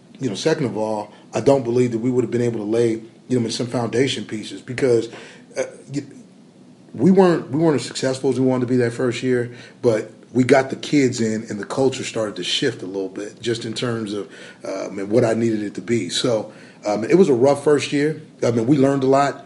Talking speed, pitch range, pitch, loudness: 245 wpm, 115-135 Hz, 125 Hz, -20 LUFS